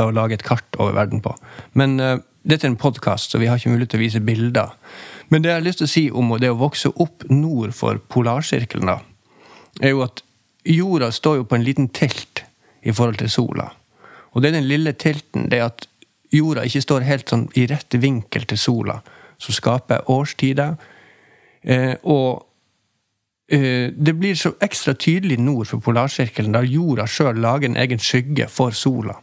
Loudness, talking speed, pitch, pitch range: -19 LUFS, 195 wpm, 130 Hz, 115-145 Hz